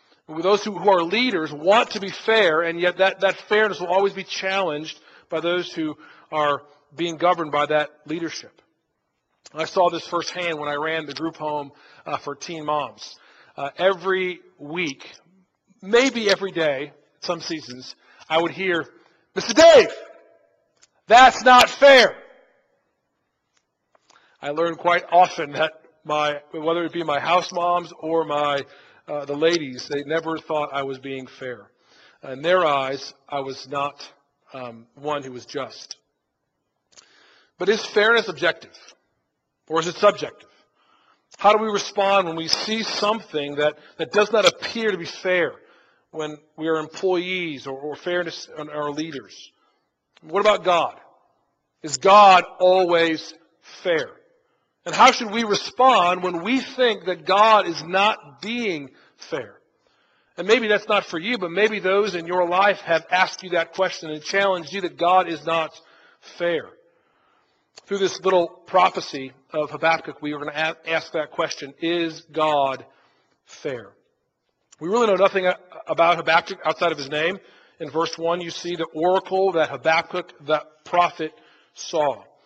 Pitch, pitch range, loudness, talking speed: 170 Hz, 155-195 Hz, -21 LUFS, 150 wpm